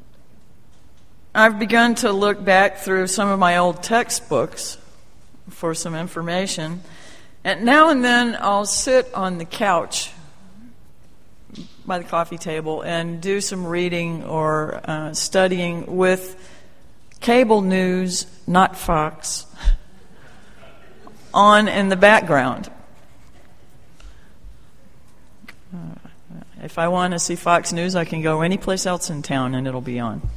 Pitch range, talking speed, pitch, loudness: 165-200 Hz, 125 wpm, 180 Hz, -19 LUFS